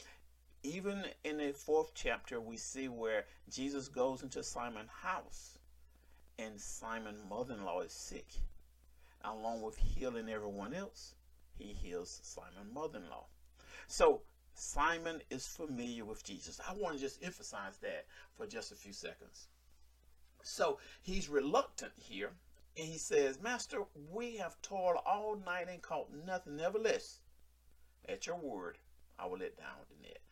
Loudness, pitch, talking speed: -41 LUFS, 115 Hz, 145 wpm